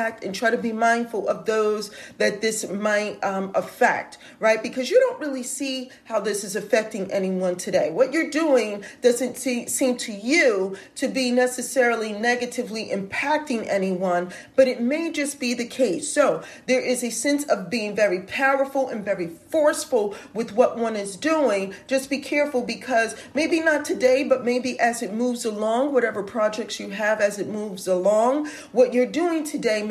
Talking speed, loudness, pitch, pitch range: 175 wpm, -23 LUFS, 245 Hz, 215-275 Hz